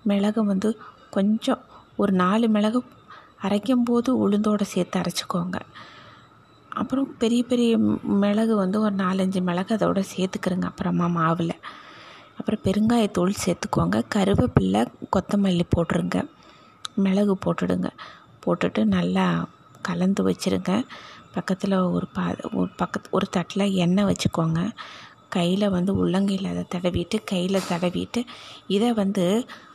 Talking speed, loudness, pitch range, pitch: 105 wpm, -24 LUFS, 180-215 Hz, 195 Hz